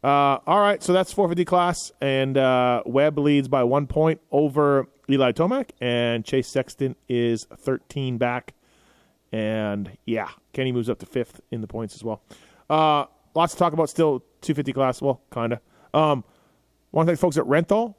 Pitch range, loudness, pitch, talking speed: 125-160 Hz, -23 LUFS, 140 Hz, 170 wpm